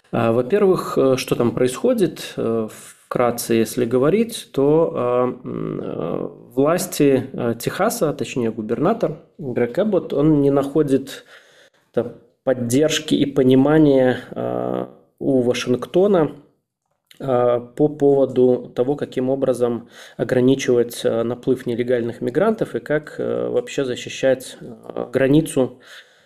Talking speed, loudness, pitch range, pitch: 80 wpm, -19 LUFS, 120-145 Hz, 130 Hz